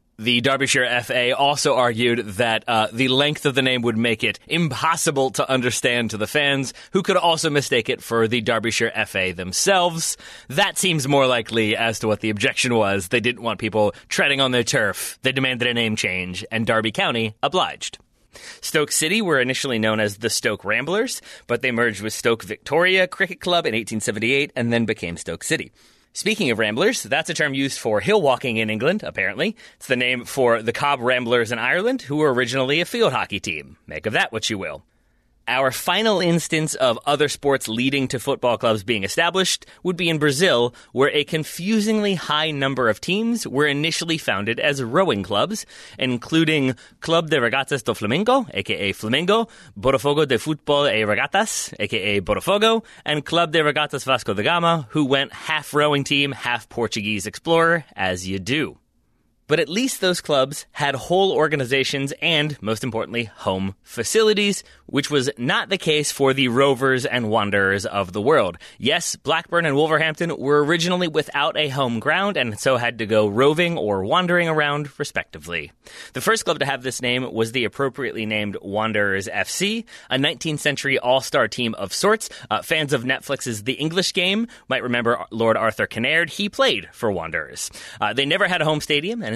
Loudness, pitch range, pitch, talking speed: -20 LUFS, 115-160 Hz, 135 Hz, 180 wpm